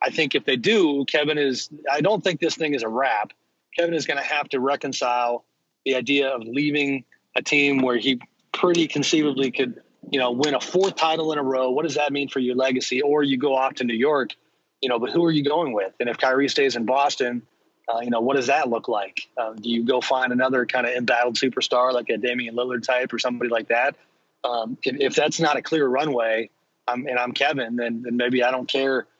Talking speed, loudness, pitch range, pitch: 235 wpm, -22 LUFS, 125-145 Hz, 130 Hz